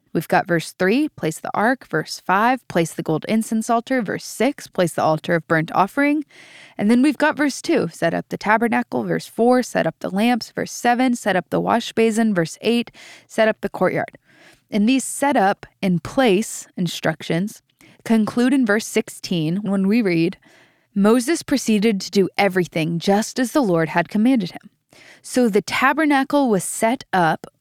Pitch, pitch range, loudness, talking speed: 215 Hz, 180-245 Hz, -20 LUFS, 185 wpm